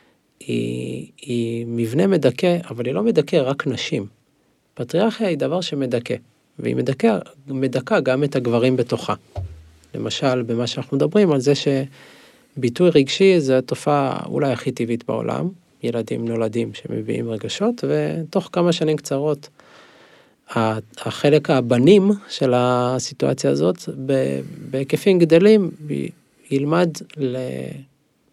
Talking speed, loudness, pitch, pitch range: 110 wpm, -20 LUFS, 135 Hz, 120-160 Hz